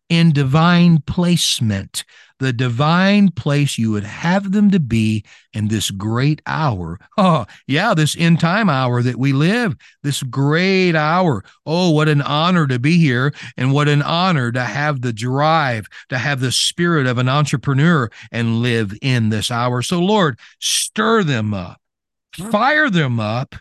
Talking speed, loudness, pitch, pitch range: 160 wpm, -16 LUFS, 145 Hz, 120-165 Hz